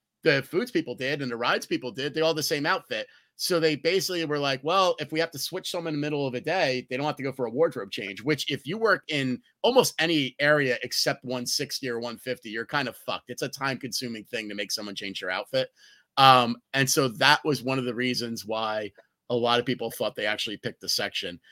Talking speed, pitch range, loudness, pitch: 245 wpm, 120-150 Hz, -26 LUFS, 130 Hz